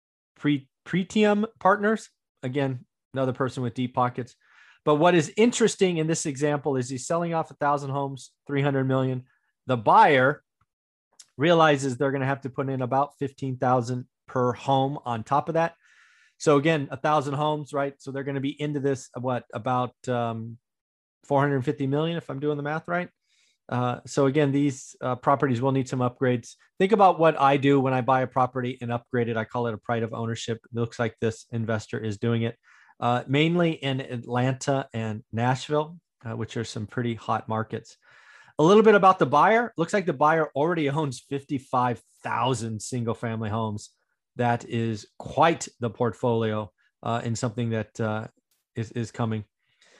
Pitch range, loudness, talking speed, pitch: 120-150 Hz, -25 LUFS, 175 wpm, 135 Hz